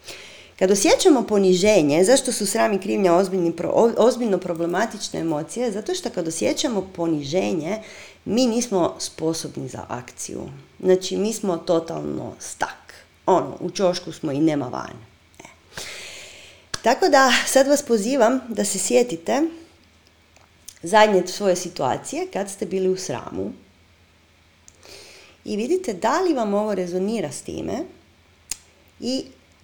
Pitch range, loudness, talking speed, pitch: 165-230 Hz, -21 LUFS, 120 wpm, 190 Hz